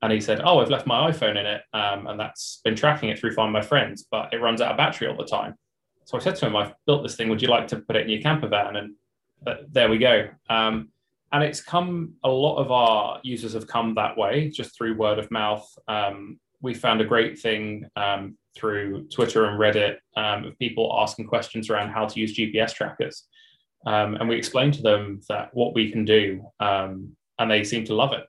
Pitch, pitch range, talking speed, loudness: 110 Hz, 105-120 Hz, 235 wpm, -24 LUFS